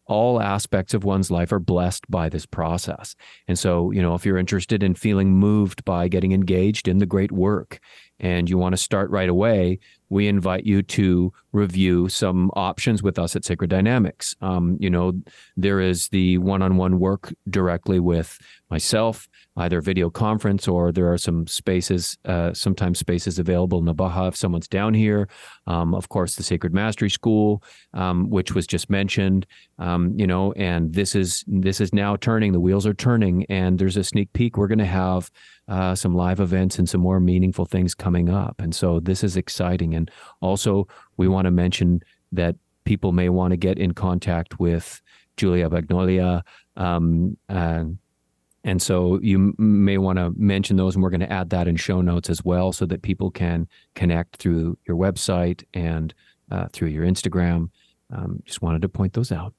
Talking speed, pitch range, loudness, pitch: 185 wpm, 90-100 Hz, -22 LUFS, 95 Hz